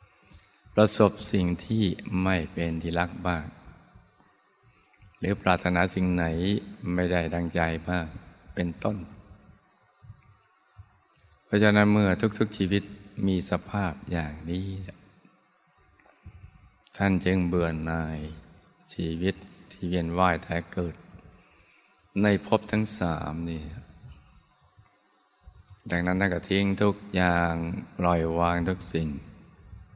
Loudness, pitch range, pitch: -27 LUFS, 85-100 Hz, 90 Hz